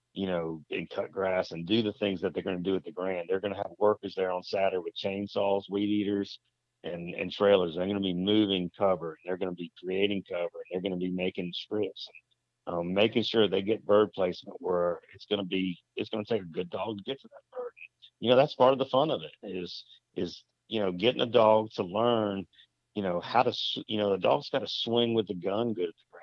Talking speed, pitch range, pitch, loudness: 250 wpm, 95-110 Hz, 100 Hz, -30 LUFS